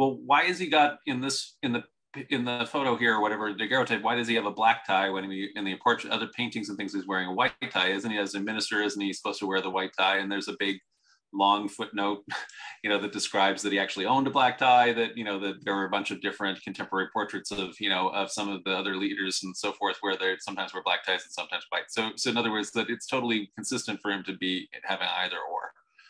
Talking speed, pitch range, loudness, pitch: 265 wpm, 95-115 Hz, -28 LUFS, 100 Hz